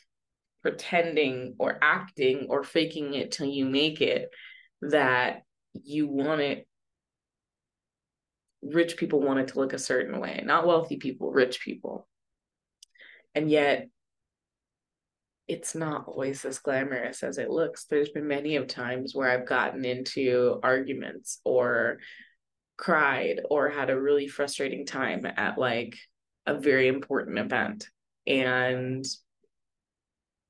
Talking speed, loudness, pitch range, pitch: 125 wpm, -28 LUFS, 130-150 Hz, 140 Hz